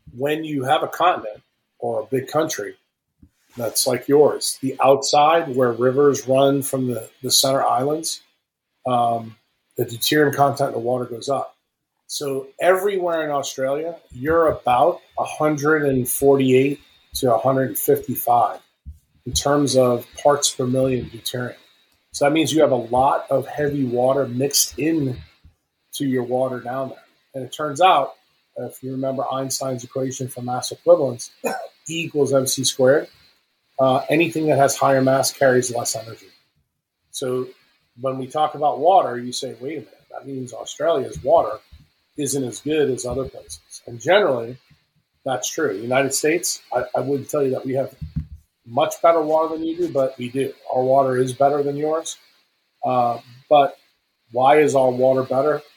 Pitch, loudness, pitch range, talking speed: 135 Hz, -20 LUFS, 125-145 Hz, 155 wpm